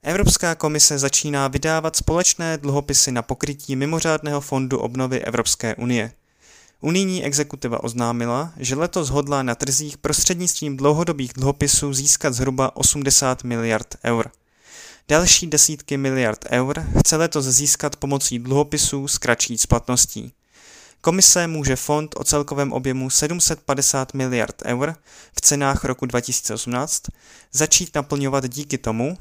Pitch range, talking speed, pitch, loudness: 130-150 Hz, 120 wpm, 140 Hz, -19 LUFS